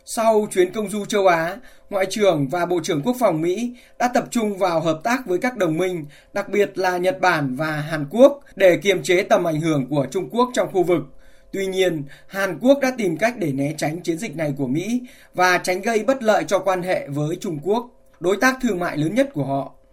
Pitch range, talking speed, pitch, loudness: 165-225 Hz, 235 wpm, 185 Hz, -21 LUFS